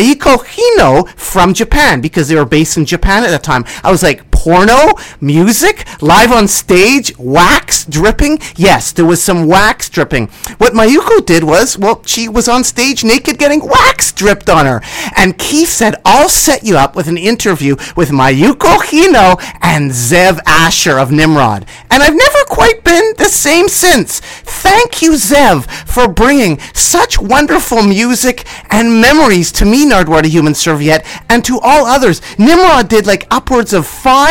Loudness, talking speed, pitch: -8 LUFS, 165 wpm, 220 Hz